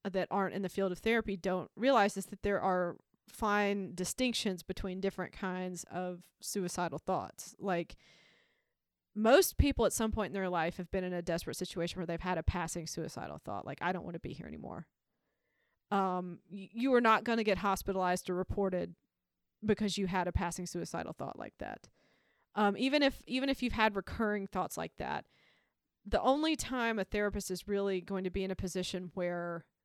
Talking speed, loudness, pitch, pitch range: 195 wpm, -34 LUFS, 190 Hz, 180-210 Hz